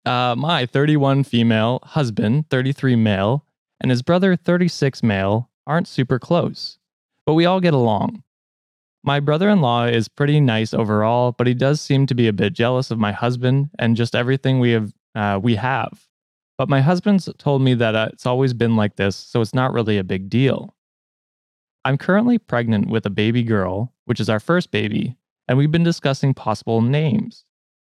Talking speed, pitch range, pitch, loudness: 185 wpm, 115-145 Hz, 125 Hz, -19 LUFS